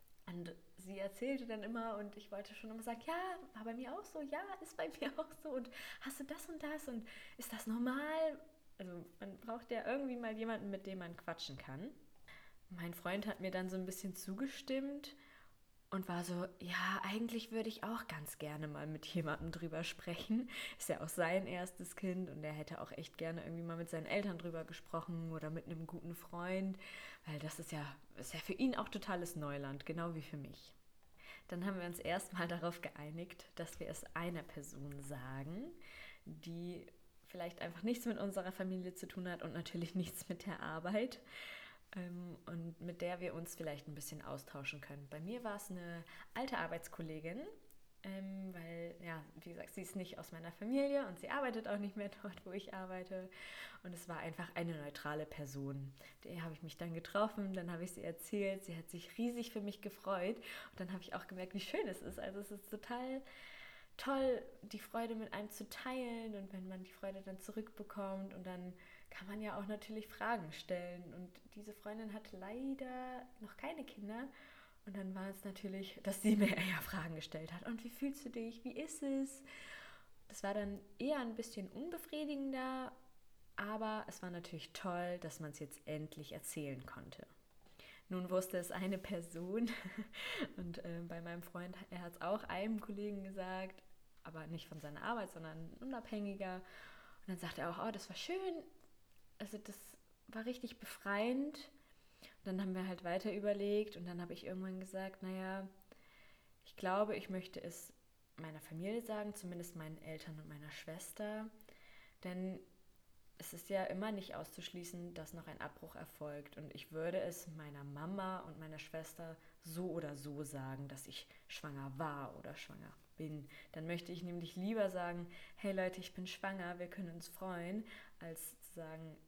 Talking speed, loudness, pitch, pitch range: 185 wpm, -45 LUFS, 185 Hz, 165-215 Hz